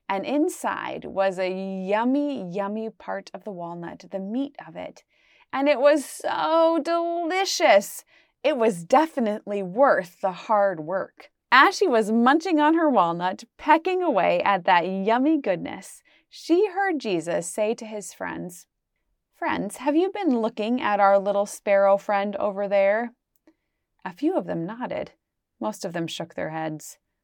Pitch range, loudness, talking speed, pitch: 195-300 Hz, -23 LUFS, 150 wpm, 220 Hz